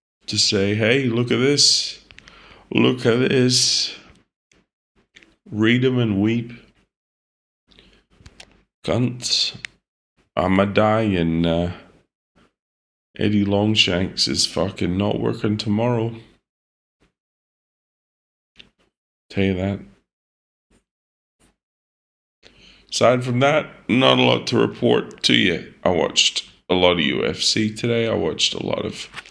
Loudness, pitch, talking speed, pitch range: -19 LUFS, 105 Hz, 105 wpm, 85-115 Hz